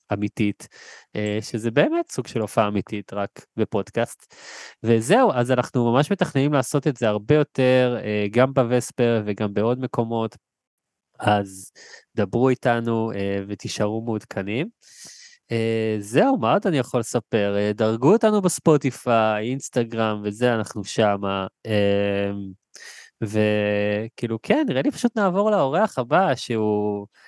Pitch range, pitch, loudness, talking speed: 105-130 Hz, 115 Hz, -22 LUFS, 110 wpm